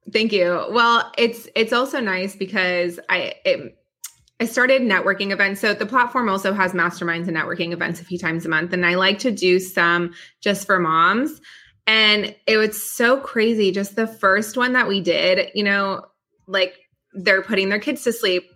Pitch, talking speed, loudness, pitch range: 195 Hz, 190 wpm, -19 LUFS, 180-225 Hz